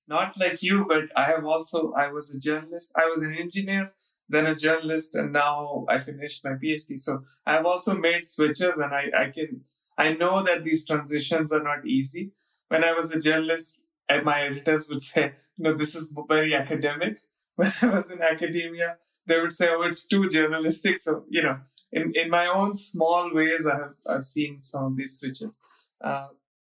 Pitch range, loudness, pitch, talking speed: 145-175 Hz, -25 LUFS, 160 Hz, 195 wpm